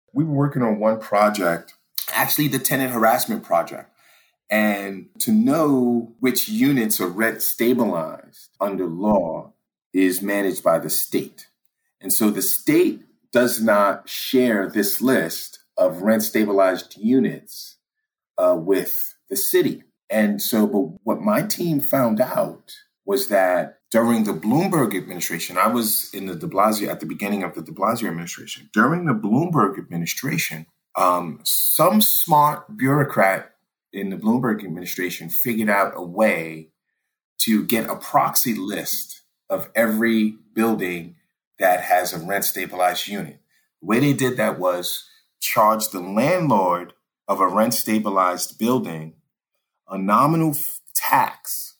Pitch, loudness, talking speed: 115 Hz, -20 LUFS, 135 wpm